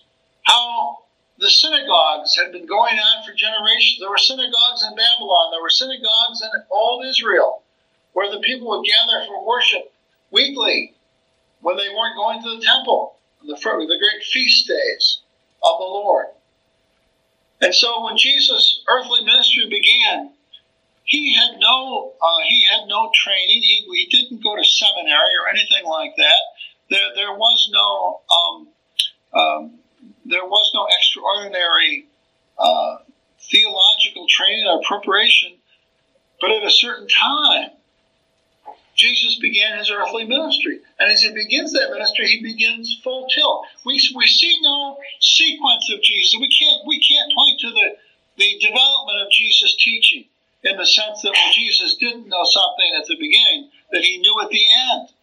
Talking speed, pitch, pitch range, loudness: 155 wpm, 240 Hz, 210-295 Hz, -14 LUFS